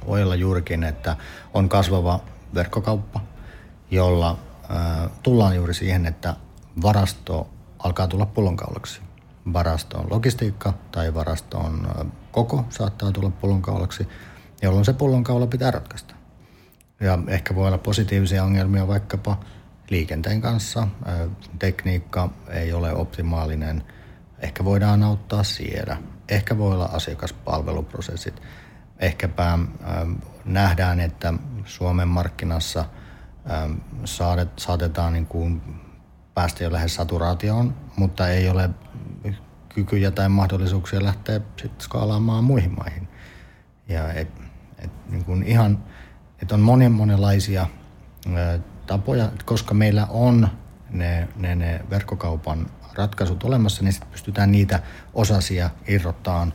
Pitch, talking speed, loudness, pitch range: 95 Hz, 110 wpm, -23 LUFS, 85-105 Hz